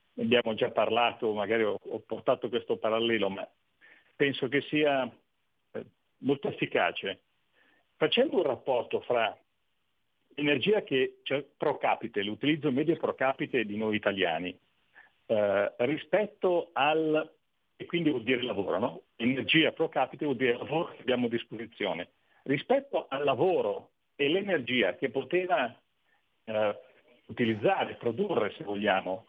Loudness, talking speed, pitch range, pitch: -29 LUFS, 125 wpm, 115-155 Hz, 135 Hz